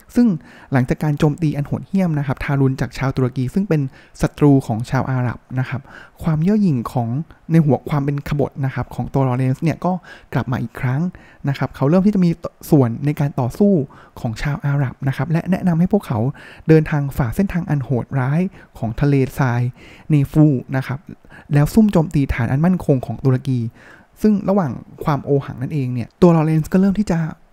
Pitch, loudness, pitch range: 140 Hz, -19 LUFS, 130-165 Hz